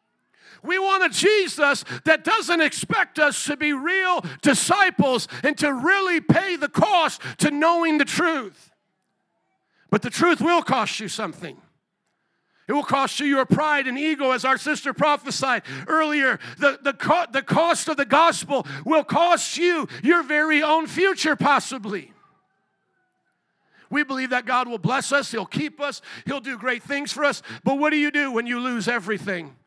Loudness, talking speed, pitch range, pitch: -21 LUFS, 170 wpm, 265-325 Hz, 290 Hz